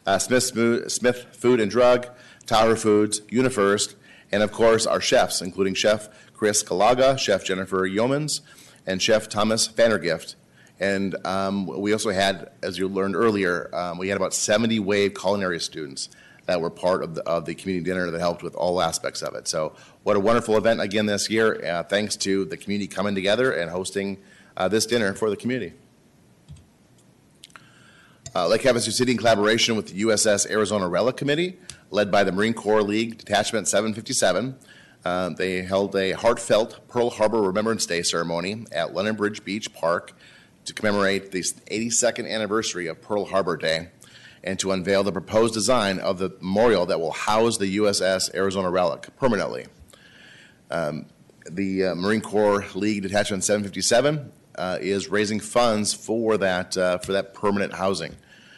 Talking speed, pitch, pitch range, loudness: 165 wpm, 105 Hz, 95-115 Hz, -23 LUFS